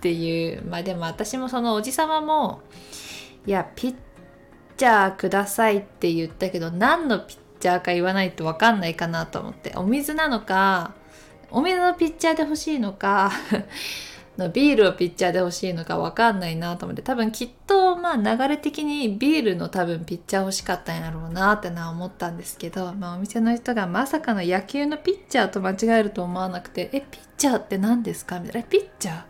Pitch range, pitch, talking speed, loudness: 180-250 Hz, 200 Hz, 405 characters per minute, -23 LUFS